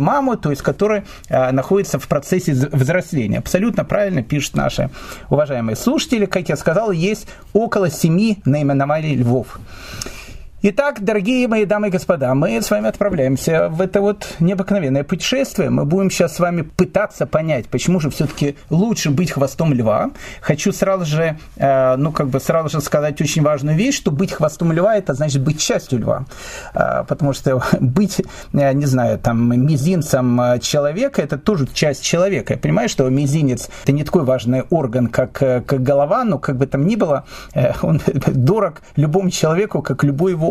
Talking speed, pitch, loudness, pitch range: 165 wpm, 155 Hz, -17 LUFS, 140-195 Hz